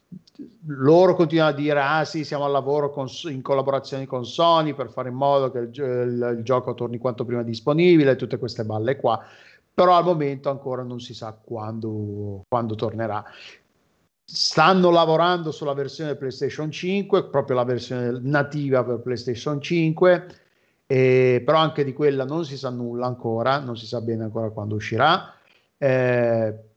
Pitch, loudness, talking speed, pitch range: 135 Hz, -22 LUFS, 160 wpm, 120-150 Hz